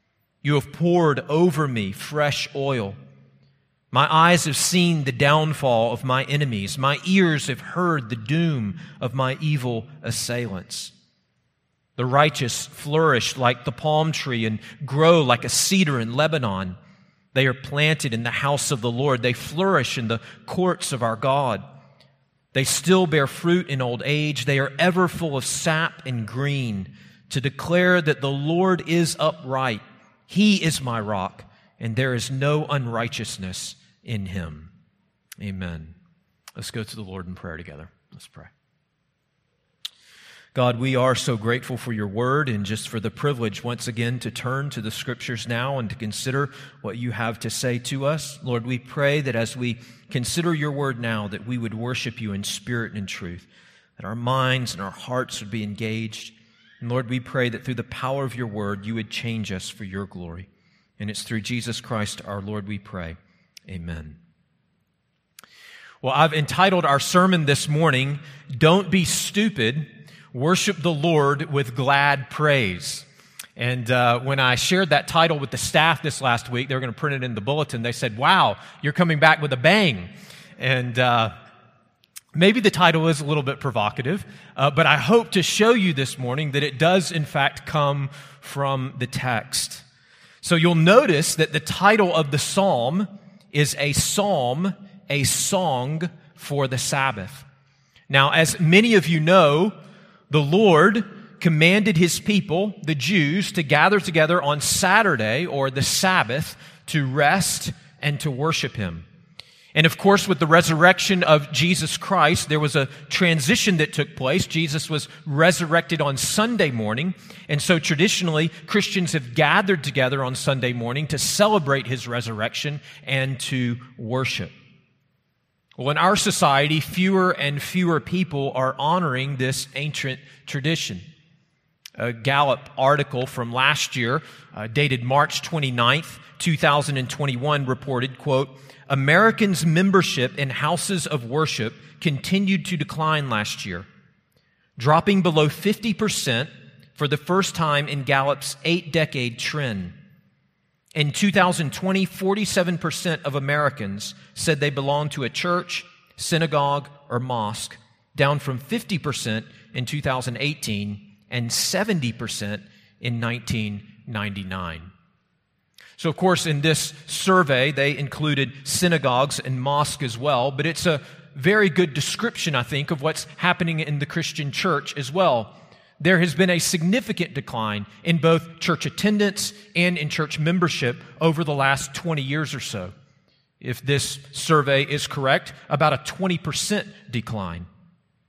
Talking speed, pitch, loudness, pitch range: 155 wpm, 145 Hz, -21 LUFS, 125-165 Hz